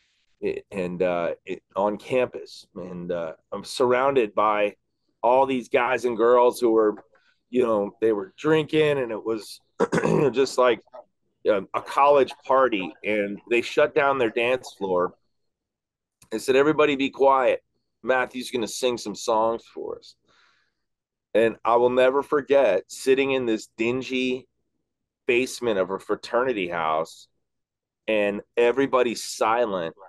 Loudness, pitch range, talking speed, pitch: -23 LUFS, 105-140 Hz, 140 wpm, 125 Hz